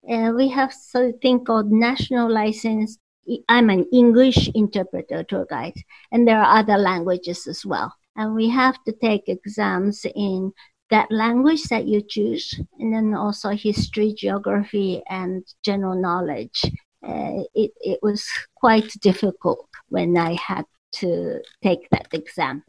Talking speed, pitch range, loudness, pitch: 140 wpm, 195-235 Hz, -21 LUFS, 215 Hz